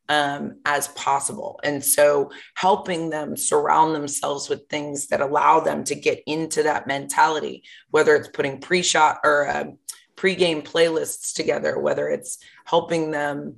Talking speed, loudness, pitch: 150 wpm, -21 LUFS, 160 Hz